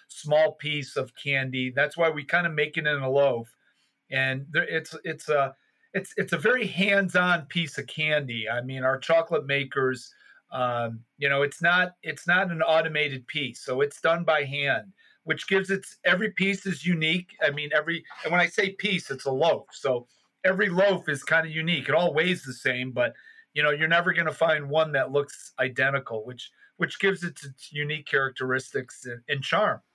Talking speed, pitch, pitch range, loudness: 200 wpm, 155 Hz, 135-175 Hz, -26 LUFS